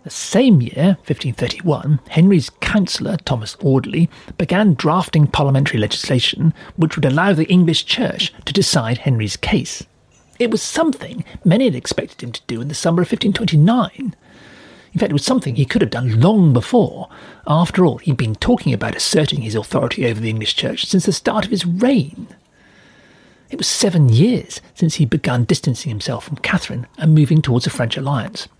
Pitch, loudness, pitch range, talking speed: 155 Hz, -17 LUFS, 130-190 Hz, 175 wpm